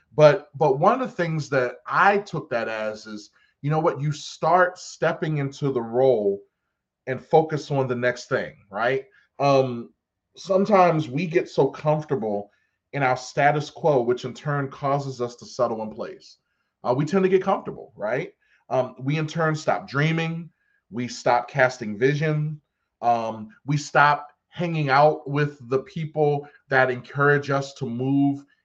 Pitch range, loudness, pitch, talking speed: 130-155 Hz, -23 LUFS, 145 Hz, 160 wpm